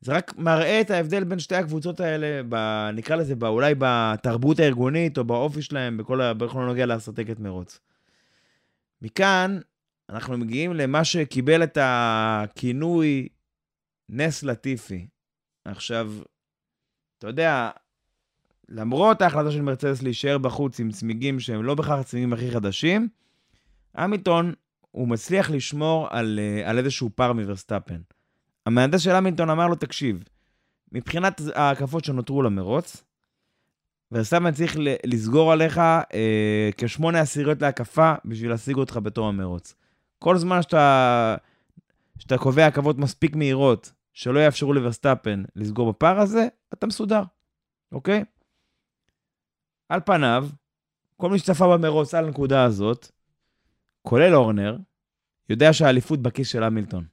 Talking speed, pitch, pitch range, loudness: 120 wpm, 135 Hz, 115-160 Hz, -22 LUFS